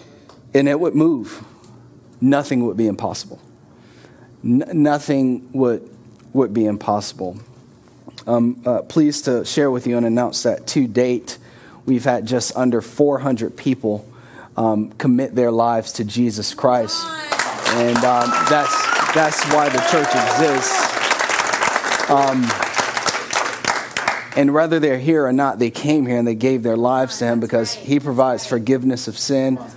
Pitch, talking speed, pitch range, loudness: 125 Hz, 145 wpm, 115-135 Hz, -18 LUFS